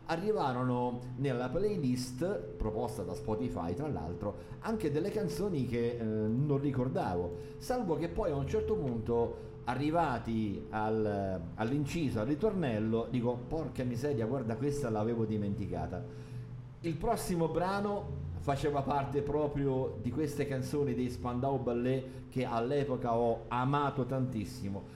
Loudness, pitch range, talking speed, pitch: -34 LUFS, 115-145 Hz, 125 wpm, 125 Hz